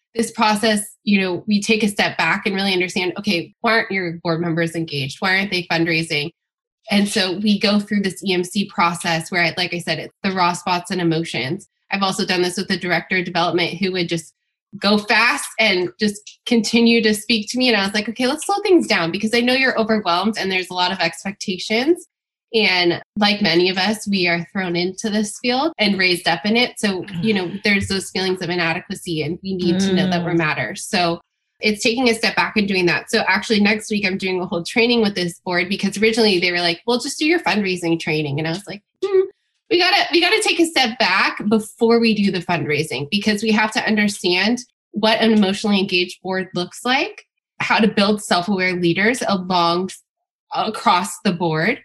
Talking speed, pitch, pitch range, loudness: 215 wpm, 195 Hz, 175-220 Hz, -18 LUFS